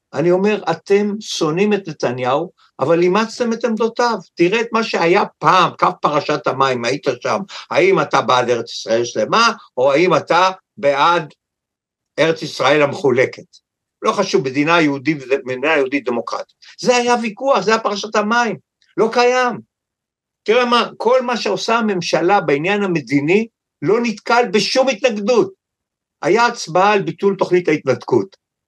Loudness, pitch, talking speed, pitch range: -16 LUFS, 190 Hz, 140 wpm, 150-230 Hz